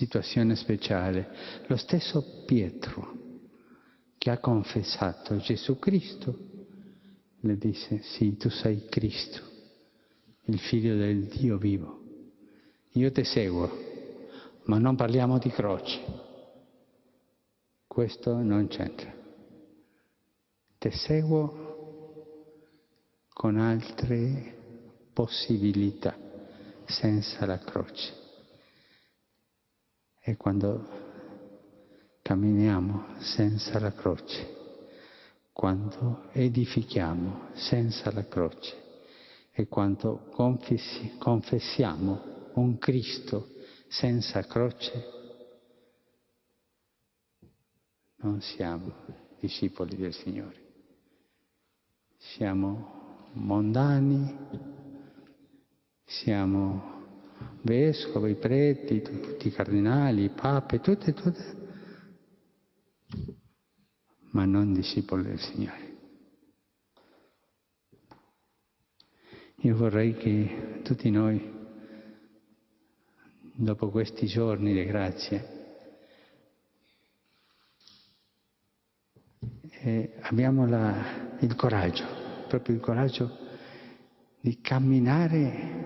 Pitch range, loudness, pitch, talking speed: 105-130 Hz, -29 LUFS, 115 Hz, 70 wpm